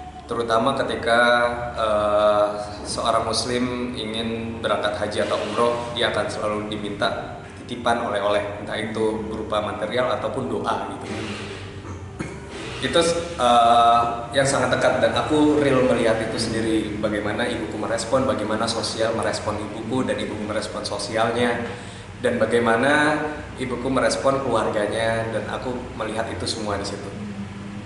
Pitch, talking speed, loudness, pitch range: 110 Hz, 125 wpm, -22 LUFS, 105-120 Hz